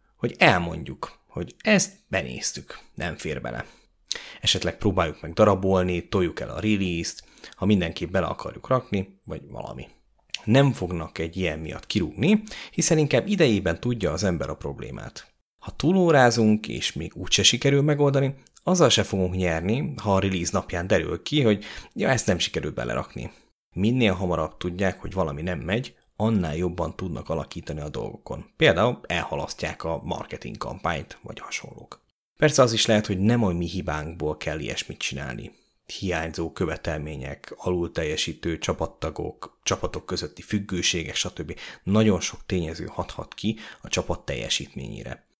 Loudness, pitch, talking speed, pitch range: -25 LUFS, 95 Hz, 145 wpm, 85-115 Hz